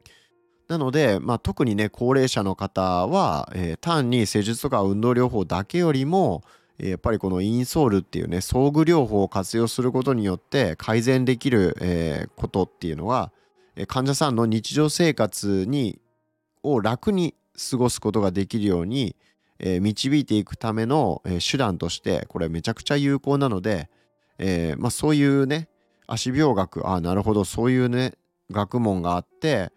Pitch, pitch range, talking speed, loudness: 115 Hz, 95-140 Hz, 325 characters per minute, -23 LUFS